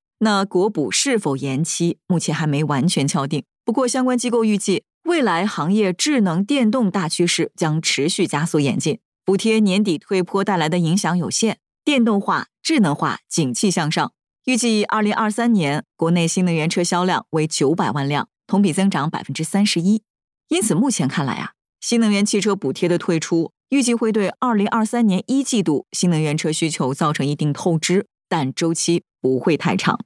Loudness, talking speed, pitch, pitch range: -19 LUFS, 285 characters per minute, 185 Hz, 160-215 Hz